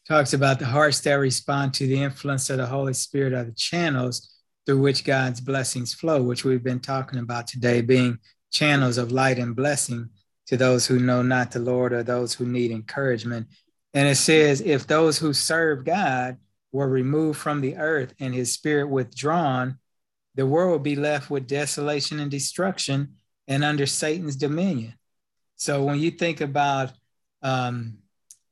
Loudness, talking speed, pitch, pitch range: -23 LUFS, 170 wpm, 135 Hz, 125-145 Hz